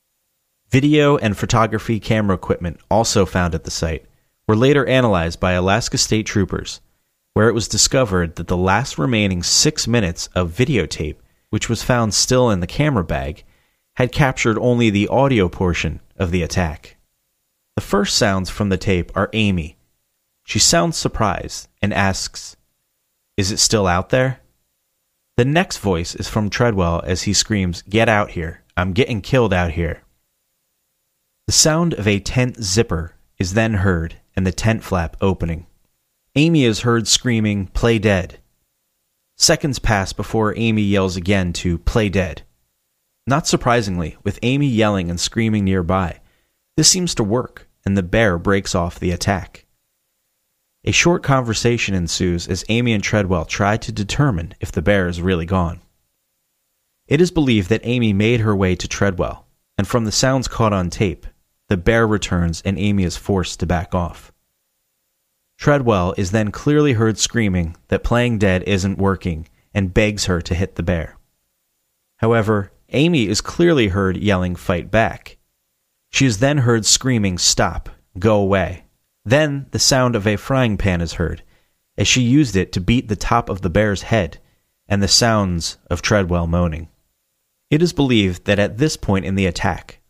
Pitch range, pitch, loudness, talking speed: 90-115 Hz, 100 Hz, -18 LUFS, 160 wpm